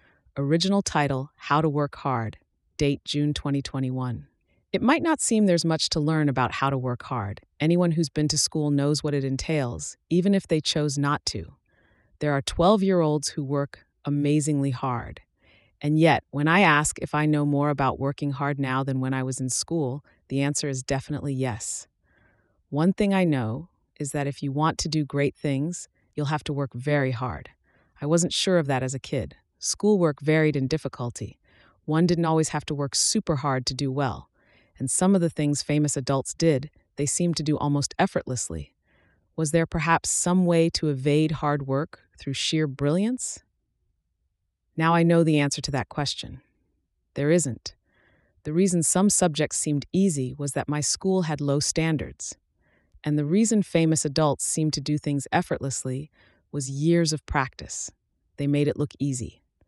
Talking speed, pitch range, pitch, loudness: 180 wpm, 135-160 Hz, 145 Hz, -25 LUFS